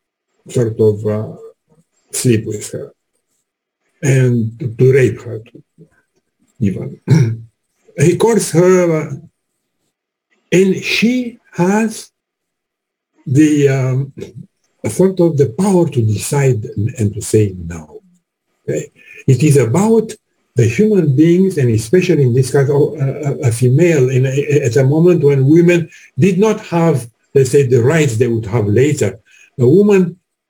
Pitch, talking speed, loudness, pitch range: 145 Hz, 140 wpm, -13 LUFS, 125-175 Hz